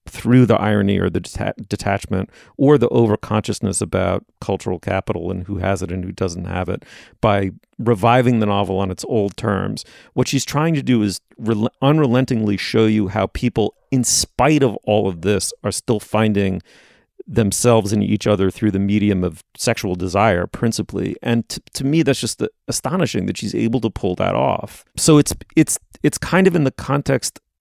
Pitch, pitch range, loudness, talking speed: 105 Hz, 95-120 Hz, -18 LUFS, 180 wpm